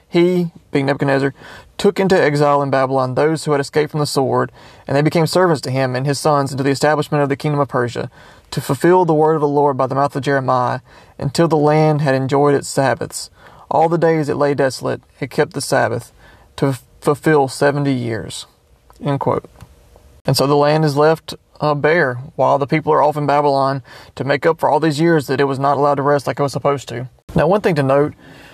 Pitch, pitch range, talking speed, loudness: 145 Hz, 135-155 Hz, 225 wpm, -16 LUFS